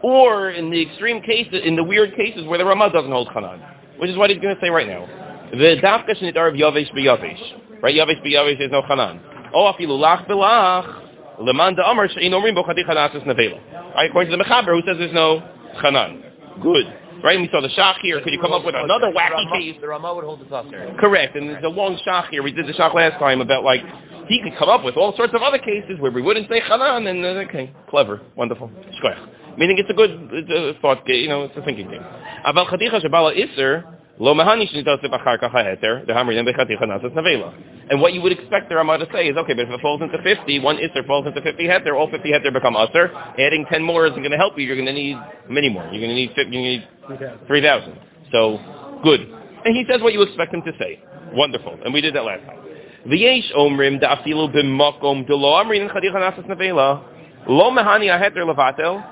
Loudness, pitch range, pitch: -17 LUFS, 145-195 Hz, 165 Hz